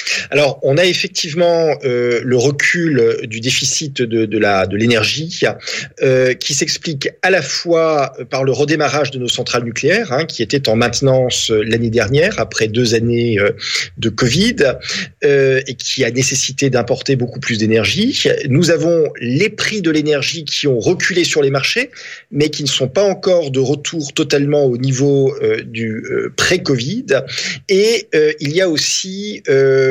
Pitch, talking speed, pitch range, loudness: 135 Hz, 165 wpm, 120-160 Hz, -15 LUFS